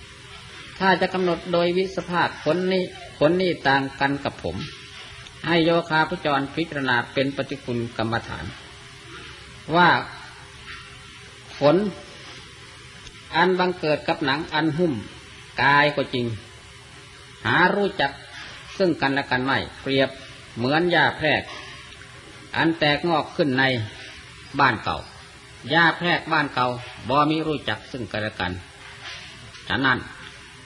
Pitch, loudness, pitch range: 140 Hz, -22 LUFS, 125-165 Hz